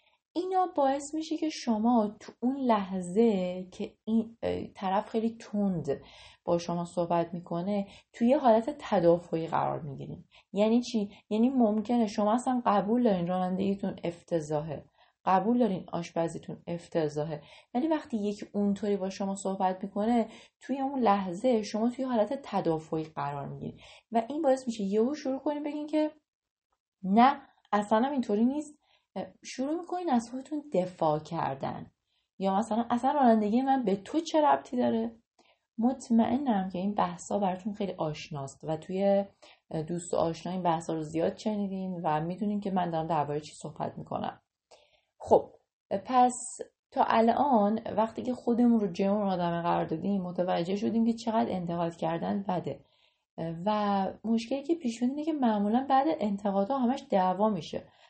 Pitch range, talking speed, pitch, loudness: 180-245 Hz, 145 wpm, 210 Hz, -30 LUFS